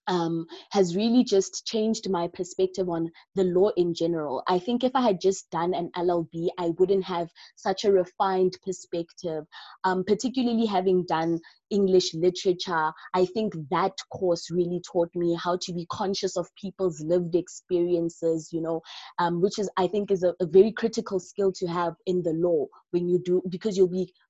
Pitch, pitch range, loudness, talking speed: 180 Hz, 175-195 Hz, -26 LUFS, 180 wpm